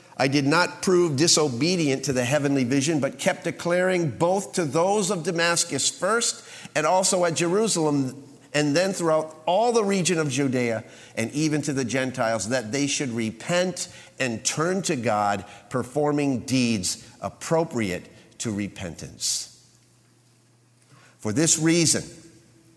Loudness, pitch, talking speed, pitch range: -23 LUFS, 145 Hz, 135 wpm, 120-170 Hz